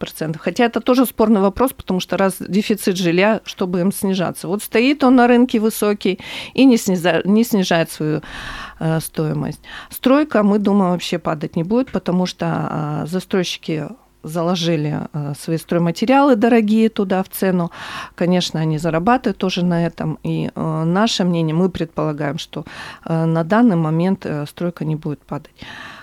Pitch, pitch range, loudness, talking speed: 185 Hz, 165-215 Hz, -18 LUFS, 140 wpm